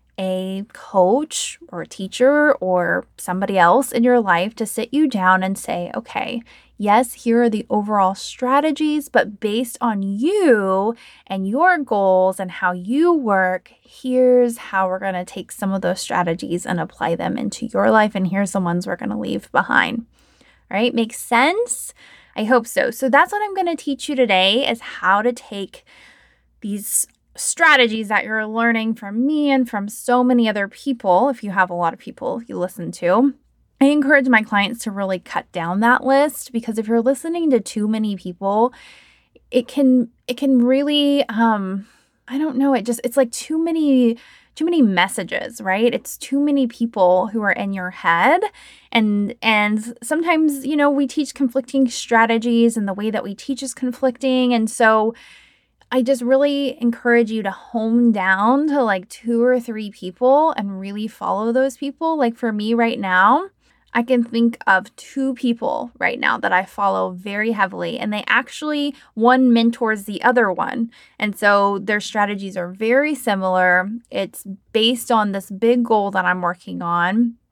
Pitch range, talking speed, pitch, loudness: 200-260 Hz, 180 wpm, 230 Hz, -18 LUFS